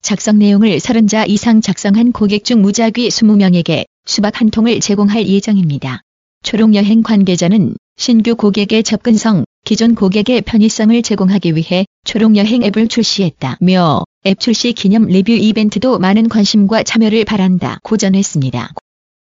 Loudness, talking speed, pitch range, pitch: -11 LUFS, 320 characters per minute, 195-225 Hz, 210 Hz